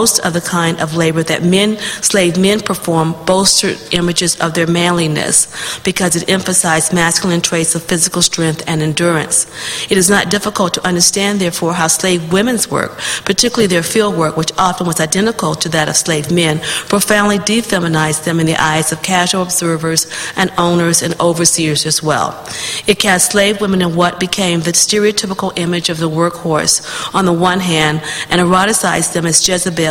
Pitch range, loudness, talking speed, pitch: 165-190 Hz, -13 LUFS, 175 wpm, 175 Hz